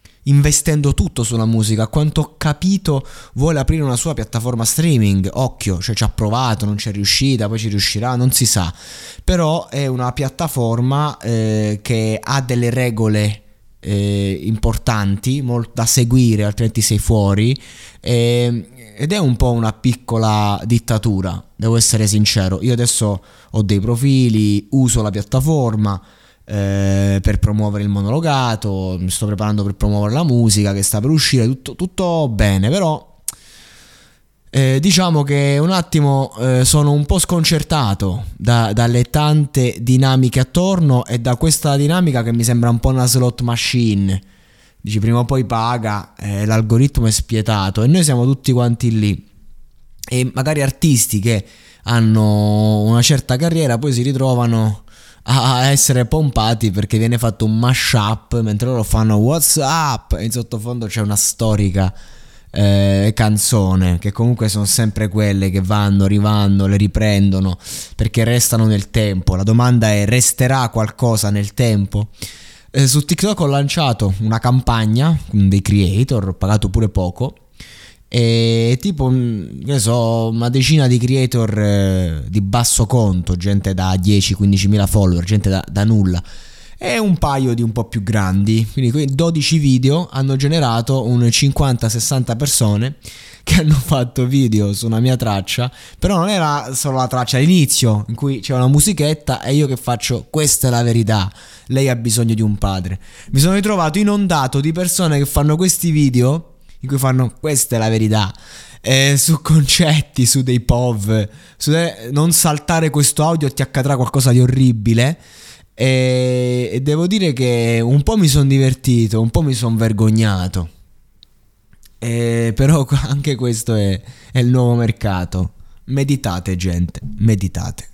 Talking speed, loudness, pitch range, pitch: 150 wpm, -15 LUFS, 105-135 Hz, 120 Hz